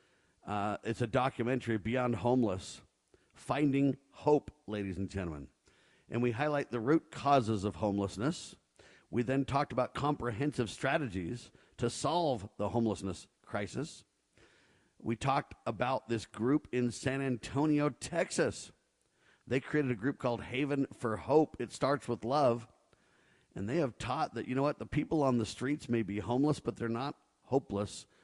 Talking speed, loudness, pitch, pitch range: 150 wpm, -34 LUFS, 125 Hz, 110-140 Hz